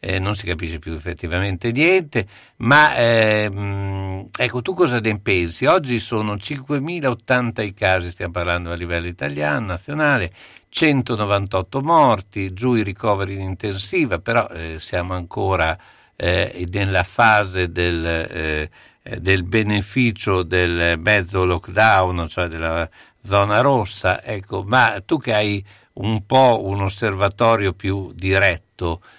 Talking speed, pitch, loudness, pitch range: 125 wpm, 100 Hz, -19 LUFS, 90-110 Hz